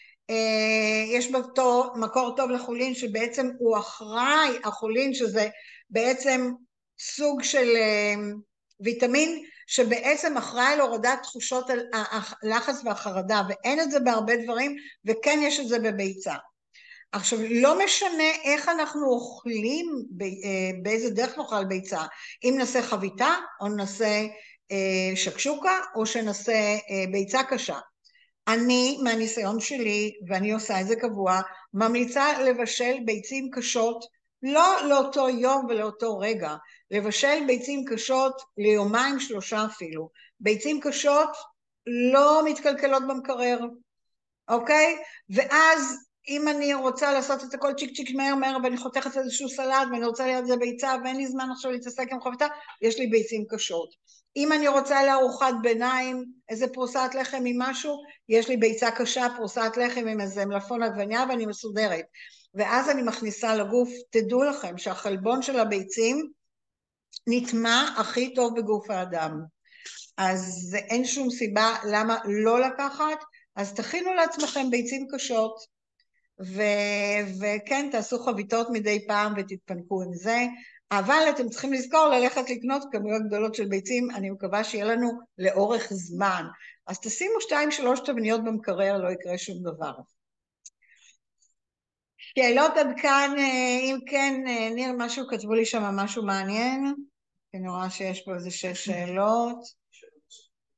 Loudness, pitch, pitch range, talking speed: -26 LUFS, 240 Hz, 215-270 Hz, 125 wpm